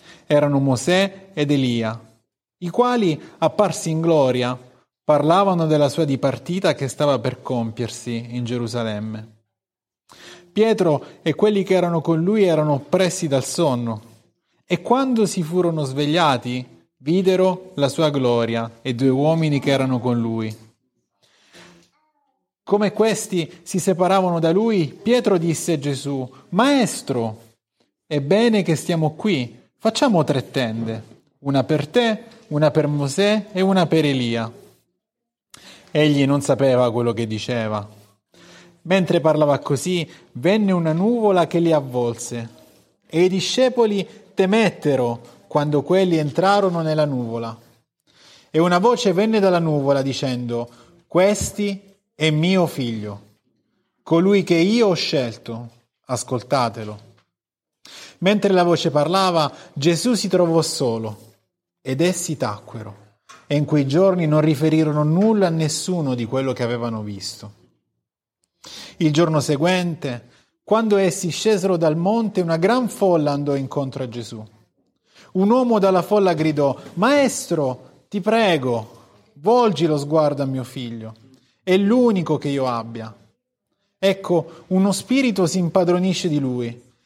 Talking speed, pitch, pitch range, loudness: 125 wpm, 155 Hz, 125-185 Hz, -19 LUFS